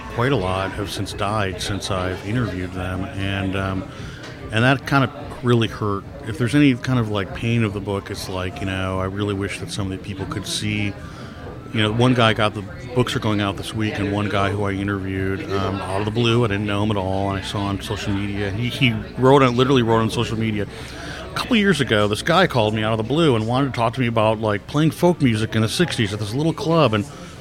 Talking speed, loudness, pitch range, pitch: 265 wpm, -21 LUFS, 100-125 Hz, 105 Hz